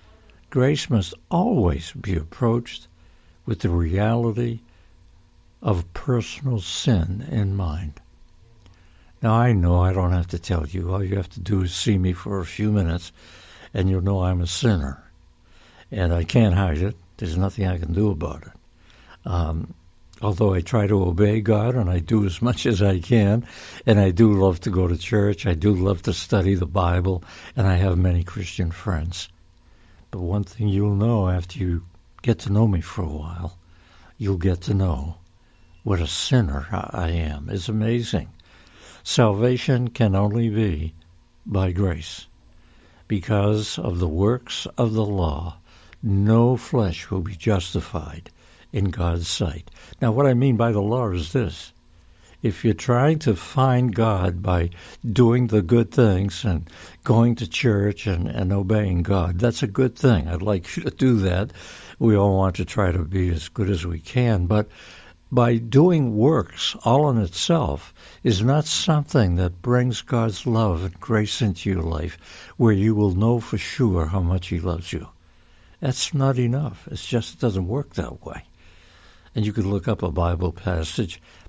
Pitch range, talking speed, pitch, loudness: 85-110 Hz, 170 wpm, 95 Hz, -22 LUFS